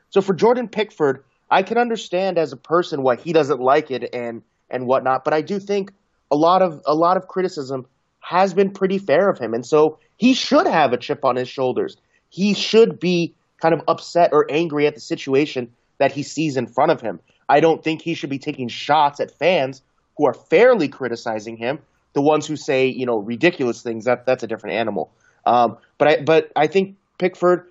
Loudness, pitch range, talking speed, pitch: -19 LUFS, 130-185 Hz, 210 wpm, 155 Hz